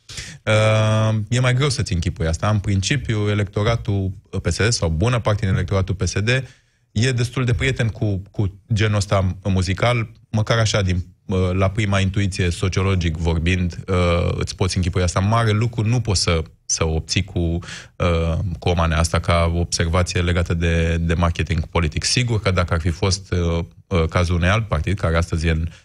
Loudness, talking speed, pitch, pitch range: -20 LUFS, 160 wpm, 95 Hz, 85-110 Hz